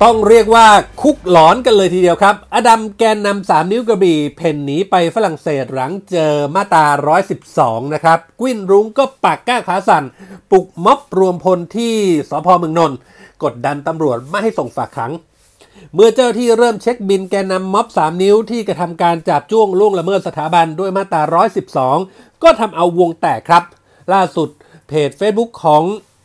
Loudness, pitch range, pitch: -13 LUFS, 160-215 Hz, 185 Hz